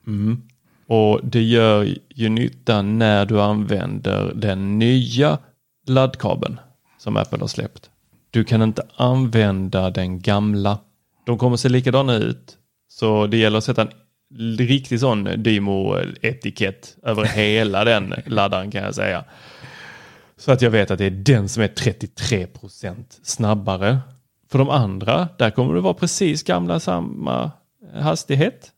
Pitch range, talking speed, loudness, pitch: 100-125 Hz, 140 wpm, -19 LUFS, 110 Hz